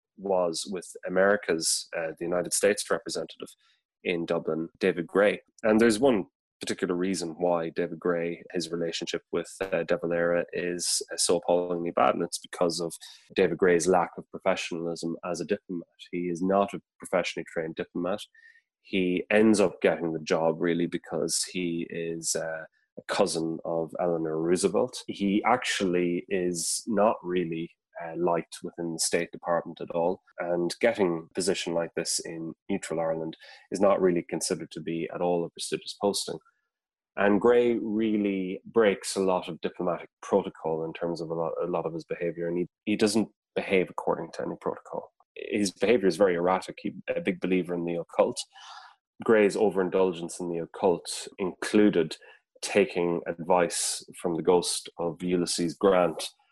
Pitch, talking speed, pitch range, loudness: 85 Hz, 160 wpm, 85-95 Hz, -28 LUFS